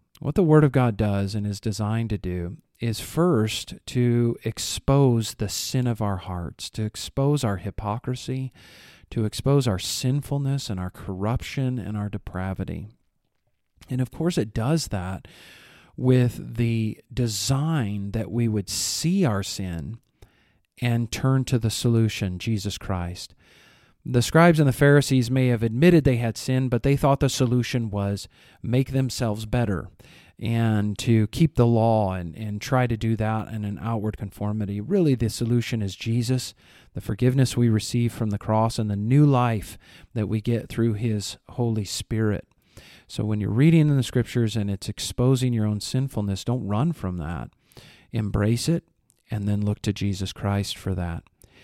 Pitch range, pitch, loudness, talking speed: 100-125 Hz, 115 Hz, -24 LUFS, 165 wpm